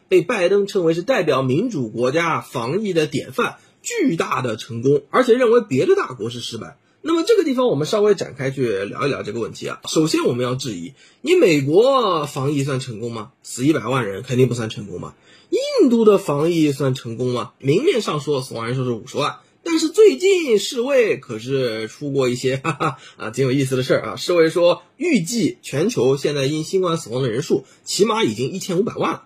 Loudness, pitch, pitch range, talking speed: -19 LUFS, 145 Hz, 130-210 Hz, 315 characters per minute